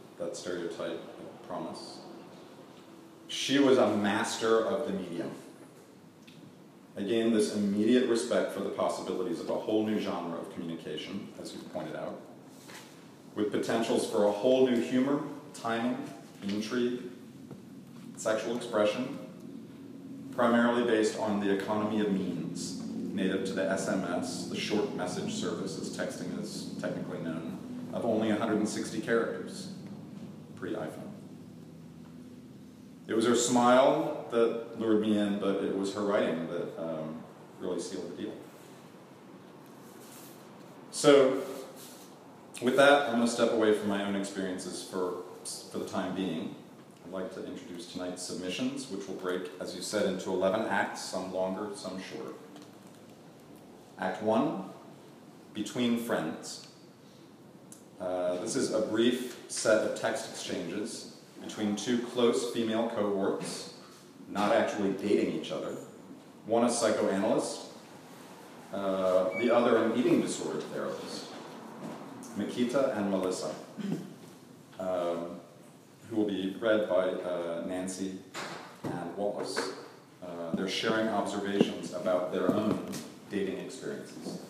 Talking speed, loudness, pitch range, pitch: 125 wpm, -31 LUFS, 95-115 Hz, 105 Hz